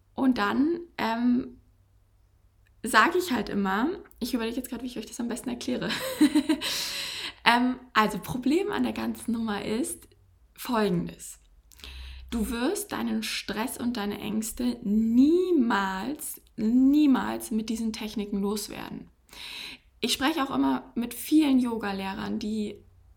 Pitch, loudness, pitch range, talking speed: 225 Hz, -27 LUFS, 195-255 Hz, 125 wpm